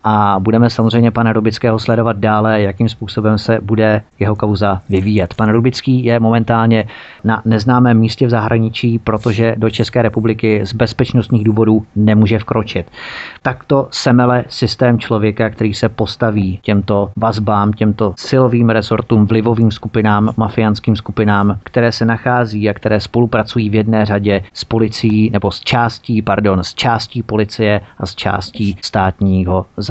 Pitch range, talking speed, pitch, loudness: 105-115 Hz, 140 wpm, 110 Hz, -14 LUFS